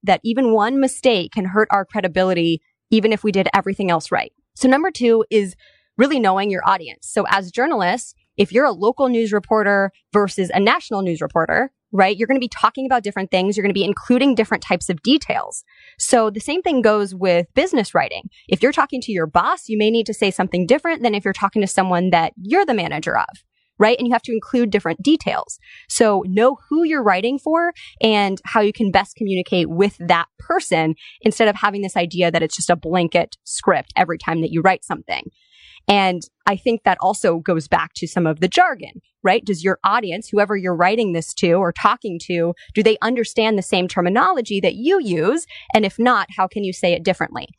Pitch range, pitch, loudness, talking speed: 185-235 Hz, 205 Hz, -18 LUFS, 210 wpm